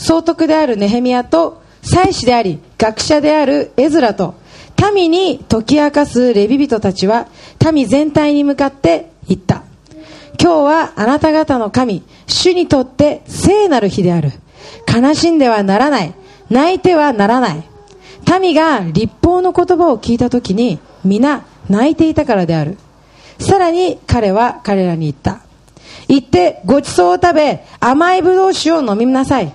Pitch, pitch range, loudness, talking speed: 265 Hz, 205-320 Hz, -13 LUFS, 290 characters per minute